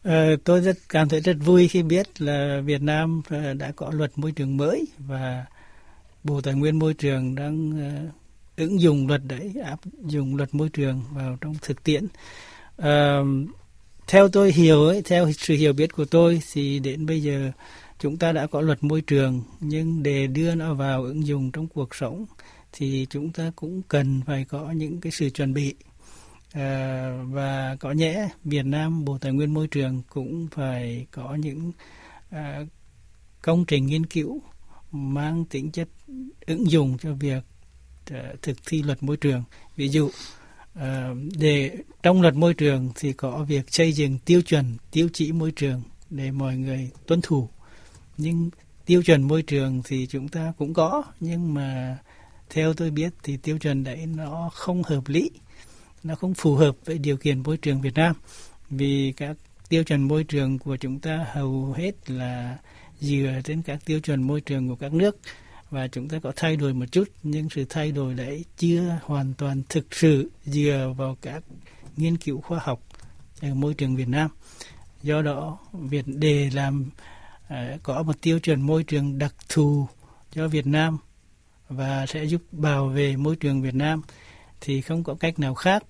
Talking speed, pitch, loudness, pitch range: 175 wpm, 145 Hz, -24 LUFS, 135-160 Hz